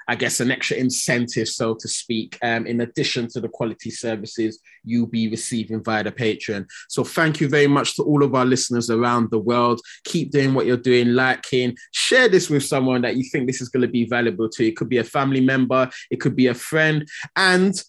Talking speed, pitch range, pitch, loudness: 225 wpm, 115-140 Hz, 125 Hz, -20 LUFS